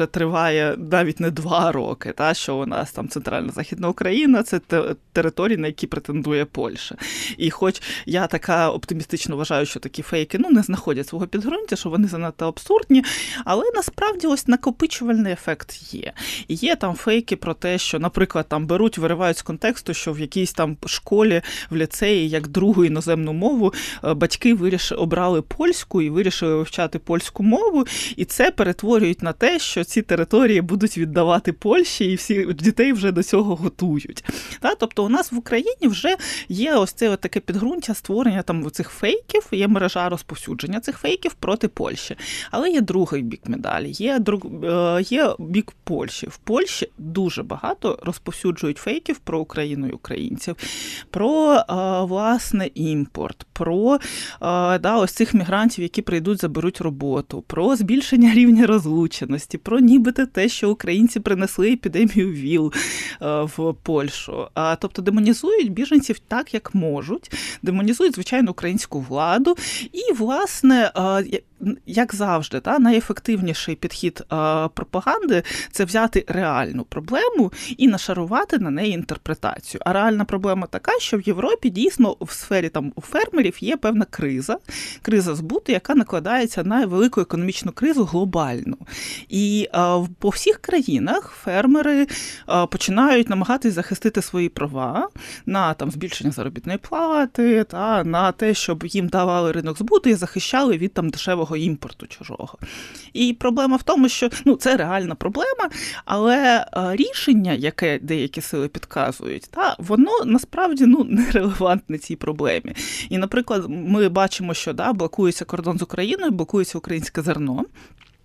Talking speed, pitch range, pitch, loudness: 145 wpm, 170-235 Hz, 195 Hz, -20 LUFS